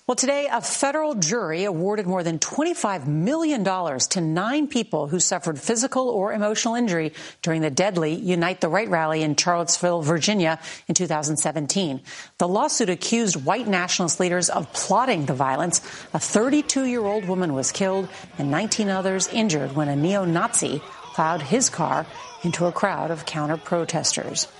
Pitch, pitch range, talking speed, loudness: 180 Hz, 160-215 Hz, 150 wpm, -23 LUFS